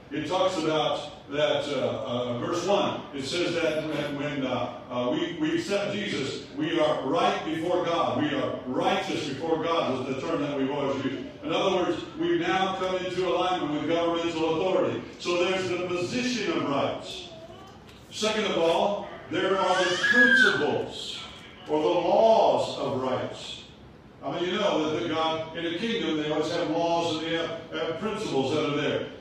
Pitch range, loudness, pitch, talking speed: 150-185 Hz, -26 LUFS, 170 Hz, 180 wpm